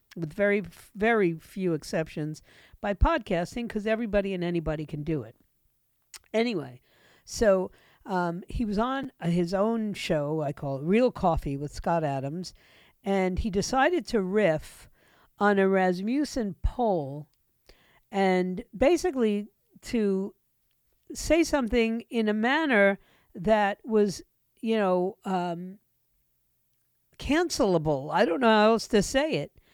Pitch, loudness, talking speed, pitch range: 195 Hz, -27 LUFS, 125 wpm, 165-225 Hz